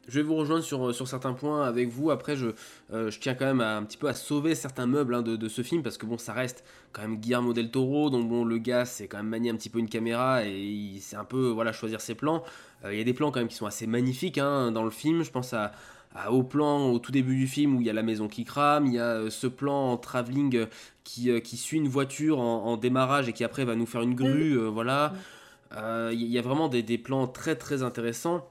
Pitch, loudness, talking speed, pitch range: 125 Hz, -29 LUFS, 280 wpm, 115-140 Hz